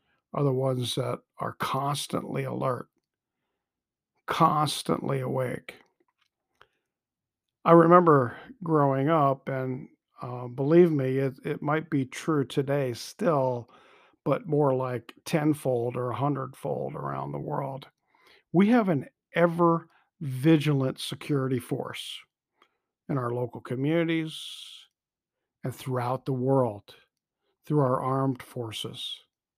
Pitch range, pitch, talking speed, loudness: 130-155 Hz, 140 Hz, 110 wpm, -27 LUFS